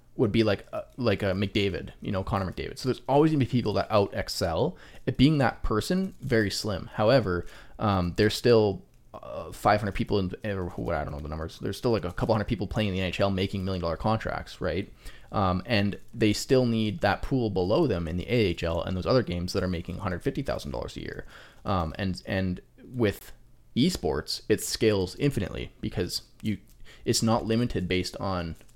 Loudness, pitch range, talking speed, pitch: -28 LUFS, 90-115 Hz, 200 wpm, 100 Hz